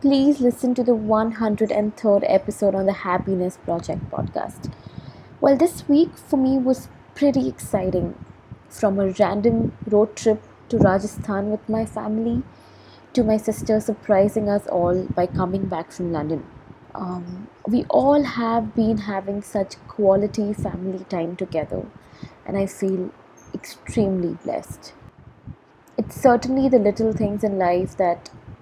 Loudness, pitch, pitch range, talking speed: -22 LUFS, 205 Hz, 185-225 Hz, 135 wpm